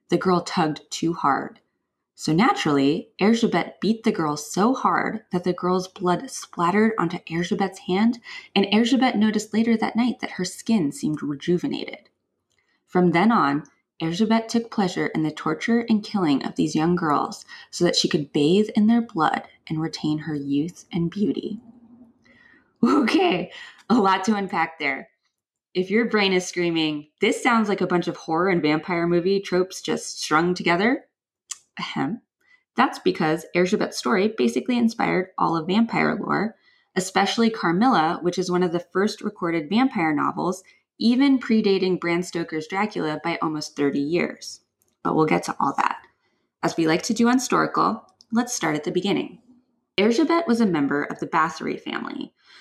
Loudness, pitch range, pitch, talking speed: -23 LUFS, 165-225 Hz, 185 Hz, 165 wpm